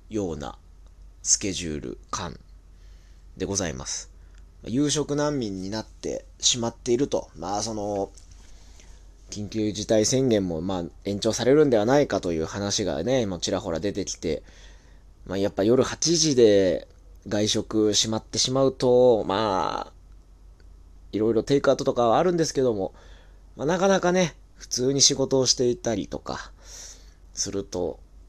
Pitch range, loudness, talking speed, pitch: 80-120 Hz, -24 LUFS, 270 characters per minute, 100 Hz